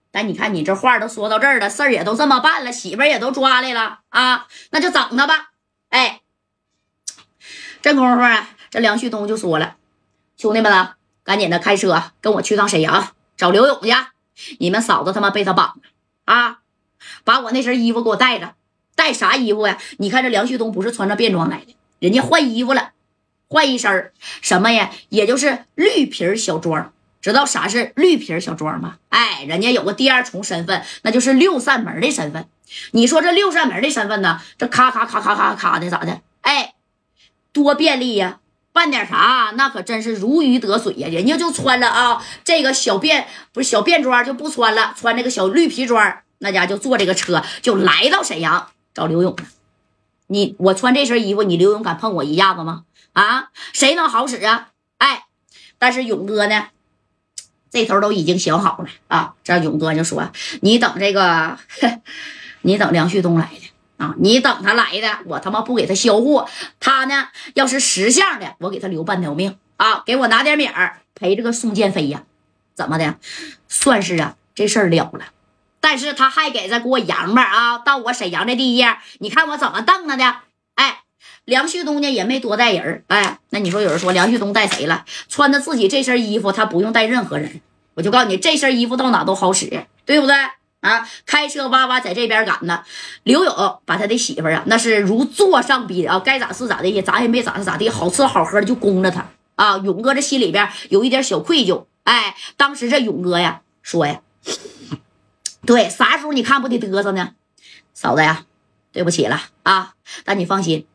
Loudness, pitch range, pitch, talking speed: -16 LUFS, 195-265 Hz, 230 Hz, 280 characters per minute